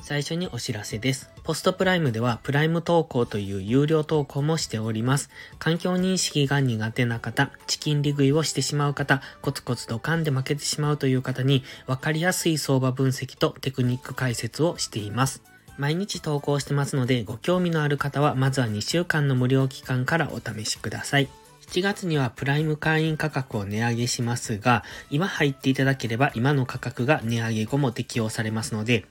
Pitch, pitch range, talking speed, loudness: 135 Hz, 120-150 Hz, 385 characters per minute, -25 LUFS